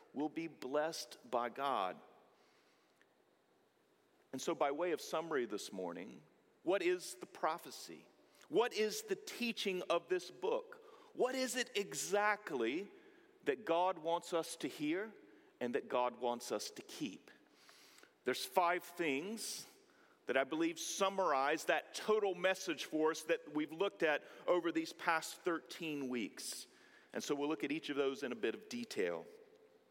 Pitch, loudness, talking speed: 185 Hz, -39 LUFS, 150 wpm